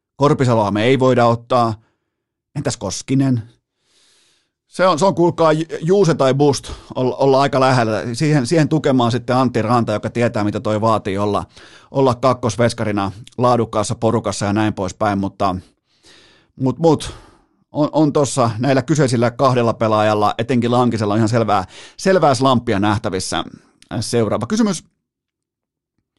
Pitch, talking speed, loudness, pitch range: 120 Hz, 130 wpm, -17 LUFS, 110-135 Hz